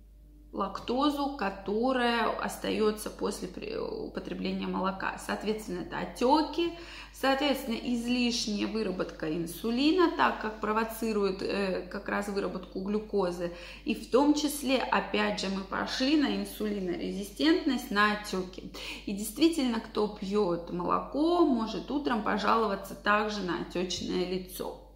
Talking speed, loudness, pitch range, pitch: 110 wpm, -30 LUFS, 195-265 Hz, 215 Hz